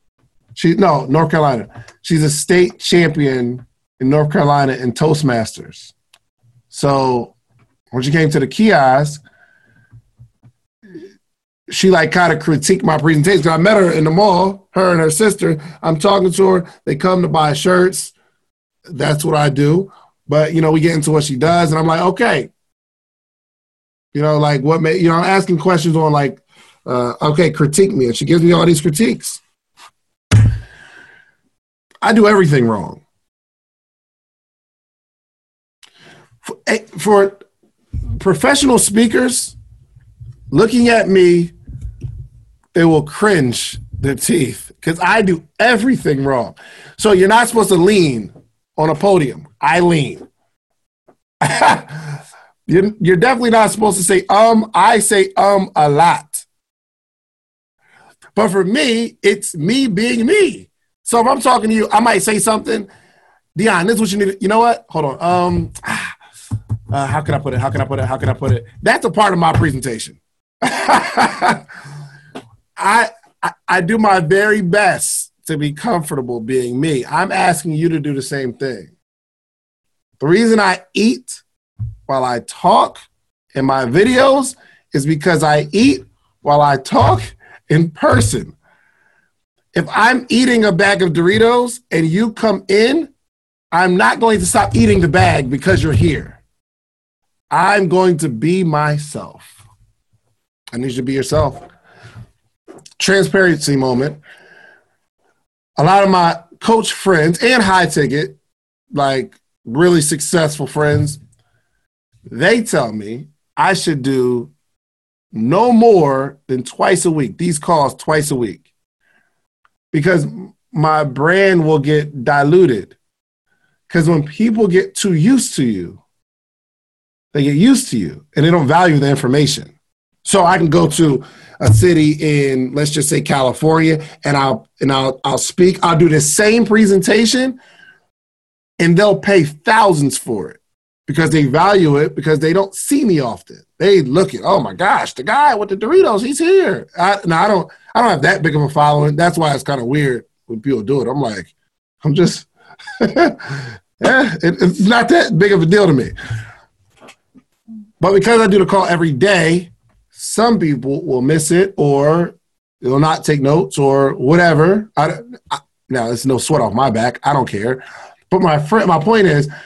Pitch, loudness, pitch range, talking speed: 160 Hz, -14 LUFS, 135-195 Hz, 155 wpm